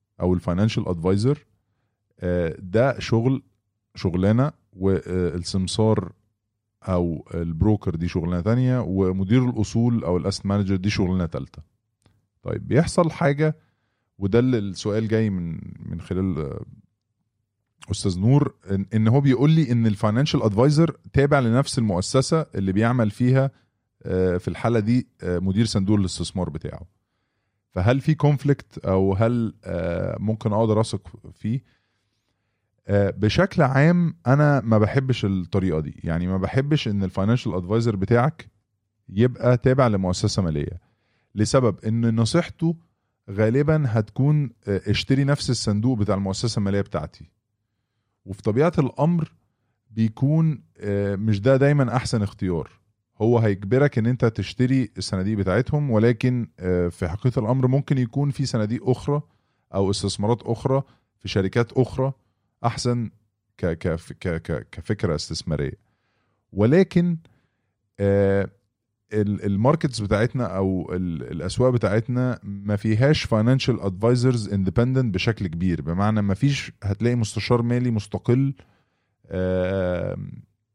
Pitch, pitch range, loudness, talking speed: 110 Hz, 95-125 Hz, -22 LUFS, 110 wpm